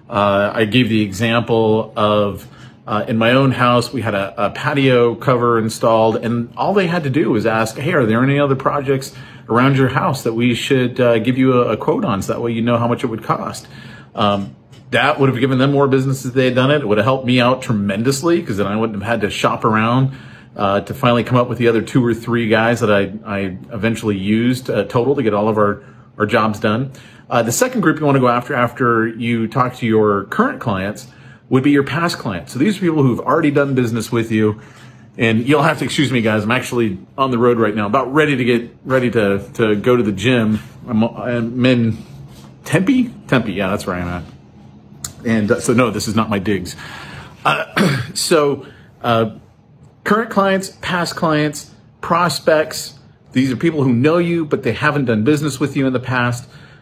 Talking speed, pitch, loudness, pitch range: 225 wpm, 120 Hz, -16 LUFS, 110-135 Hz